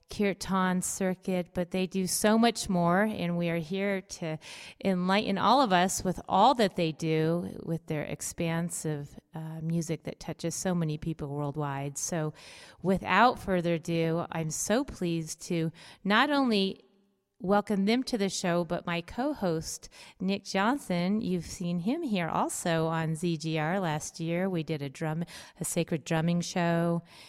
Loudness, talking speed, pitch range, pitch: -29 LUFS, 155 wpm, 165-195 Hz, 175 Hz